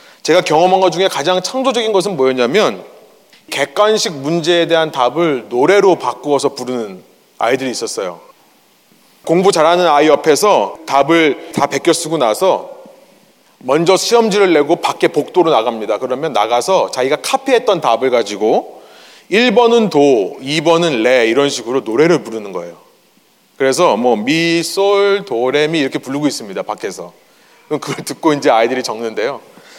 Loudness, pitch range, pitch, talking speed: -14 LUFS, 140-200 Hz, 170 Hz, 320 characters per minute